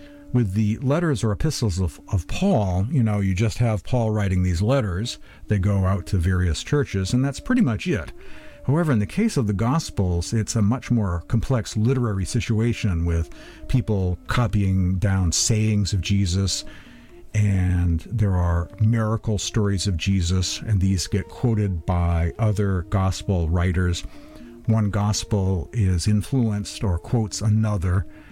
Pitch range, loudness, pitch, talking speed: 95-115 Hz, -23 LUFS, 105 Hz, 150 wpm